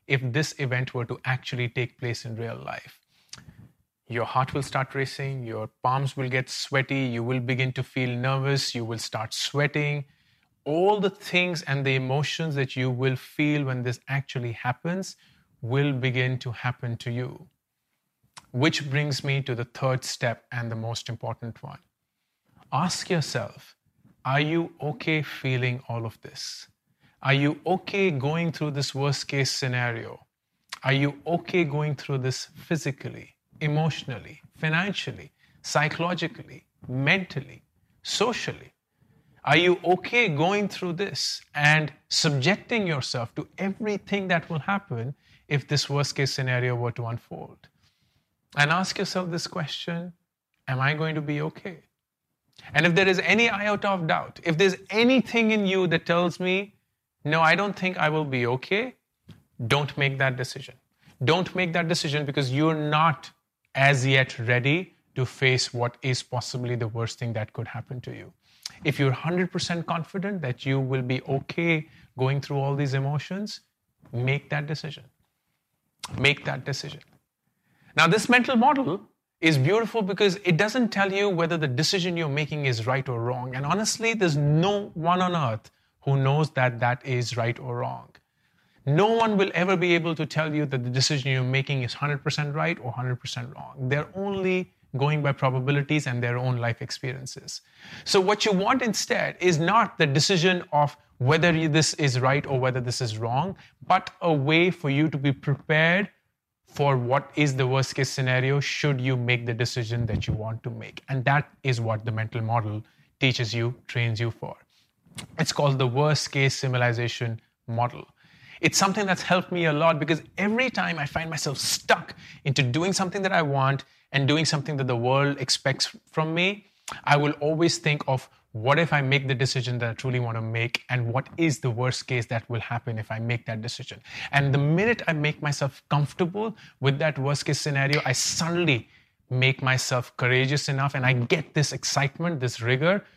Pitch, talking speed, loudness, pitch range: 140 Hz, 170 wpm, -25 LUFS, 130-165 Hz